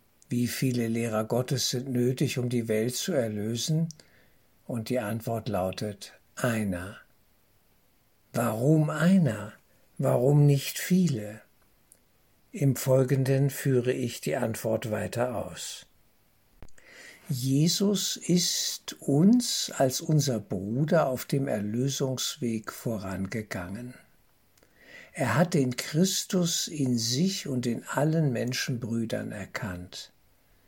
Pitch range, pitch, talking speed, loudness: 115-150 Hz, 125 Hz, 100 wpm, -28 LUFS